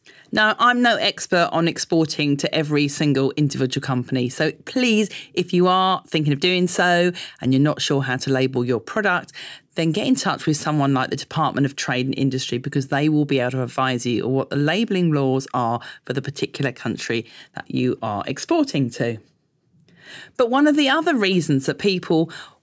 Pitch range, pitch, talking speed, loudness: 130-180 Hz, 145 Hz, 195 wpm, -20 LUFS